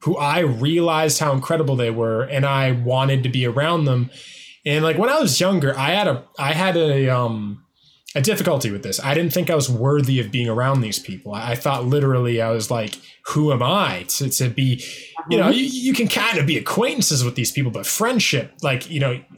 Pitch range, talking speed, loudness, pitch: 125-160 Hz, 220 wpm, -19 LUFS, 140 Hz